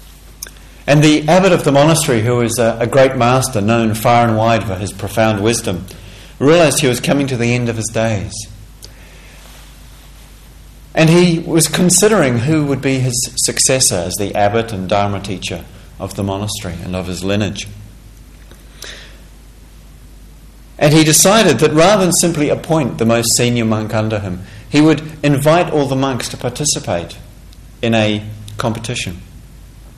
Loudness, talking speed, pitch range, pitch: -13 LUFS, 155 wpm, 100-140 Hz, 115 Hz